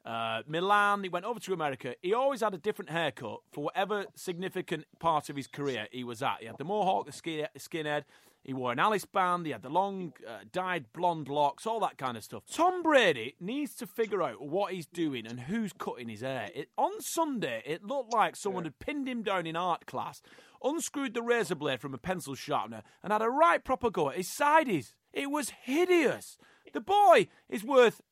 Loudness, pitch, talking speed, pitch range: -31 LUFS, 185 Hz, 215 wpm, 145-235 Hz